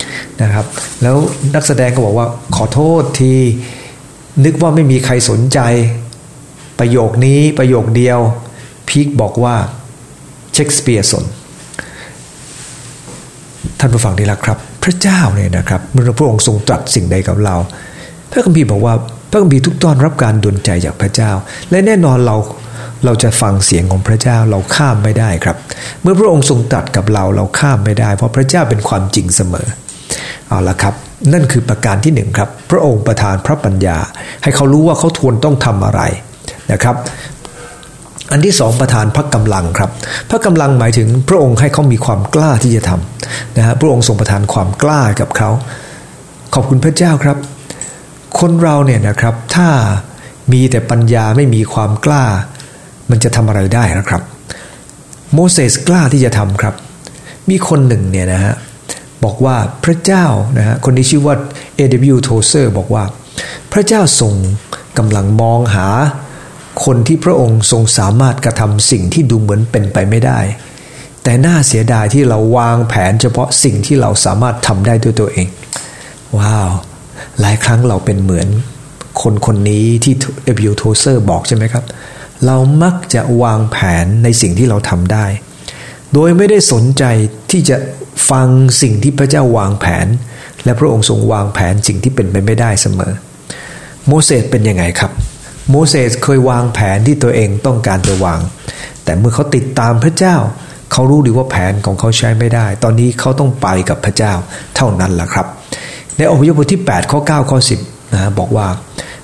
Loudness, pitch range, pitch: -11 LUFS, 105-140 Hz, 120 Hz